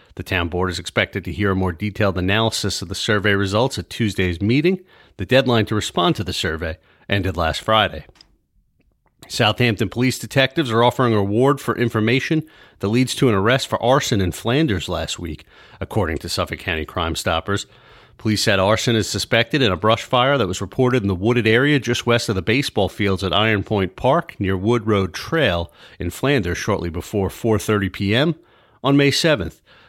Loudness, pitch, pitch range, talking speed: -19 LUFS, 105 Hz, 95-120 Hz, 185 wpm